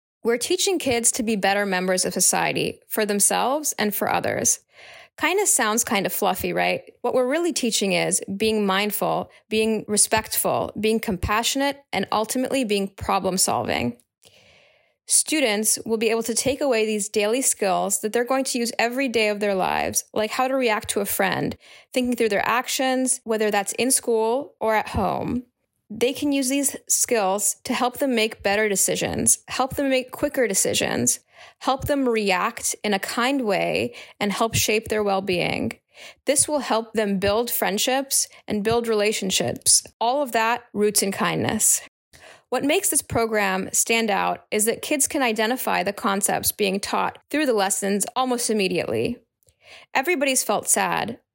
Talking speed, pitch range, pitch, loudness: 165 wpm, 205-260 Hz, 225 Hz, -22 LUFS